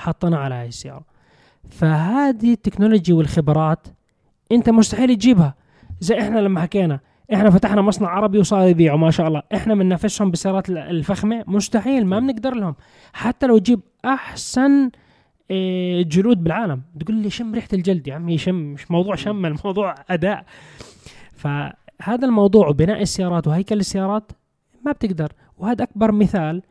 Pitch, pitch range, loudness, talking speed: 195 Hz, 165-220 Hz, -18 LUFS, 140 wpm